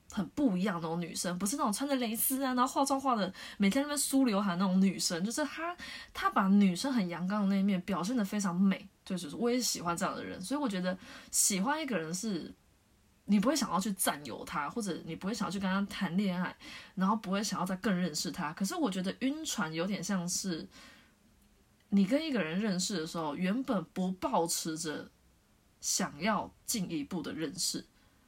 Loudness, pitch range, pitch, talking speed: -32 LUFS, 175-245 Hz, 200 Hz, 310 characters per minute